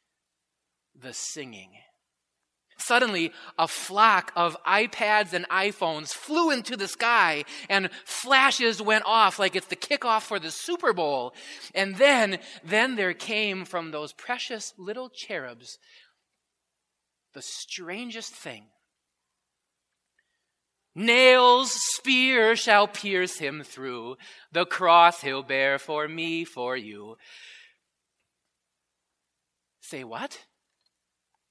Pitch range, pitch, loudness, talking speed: 165-235 Hz, 195 Hz, -23 LUFS, 105 wpm